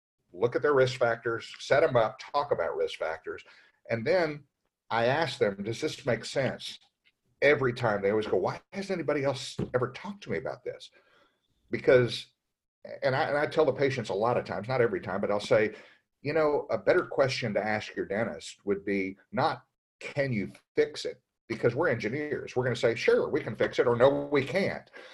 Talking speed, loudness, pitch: 205 wpm, -29 LUFS, 140 Hz